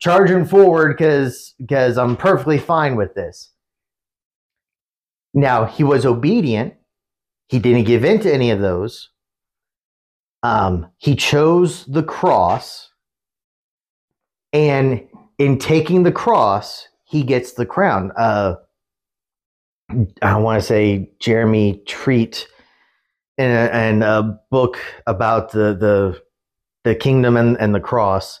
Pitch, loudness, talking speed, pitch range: 125 Hz, -16 LUFS, 110 wpm, 110-145 Hz